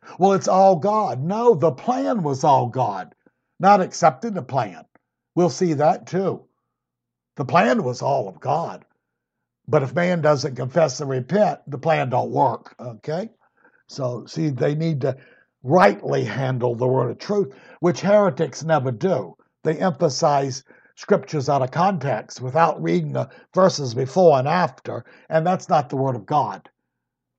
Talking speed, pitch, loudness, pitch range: 155 wpm, 155 Hz, -21 LUFS, 130-185 Hz